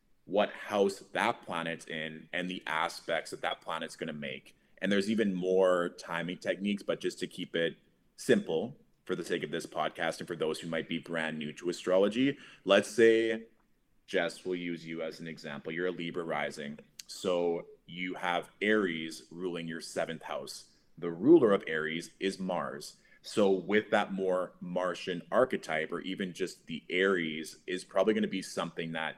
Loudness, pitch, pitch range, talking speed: -32 LUFS, 90 Hz, 80-95 Hz, 180 wpm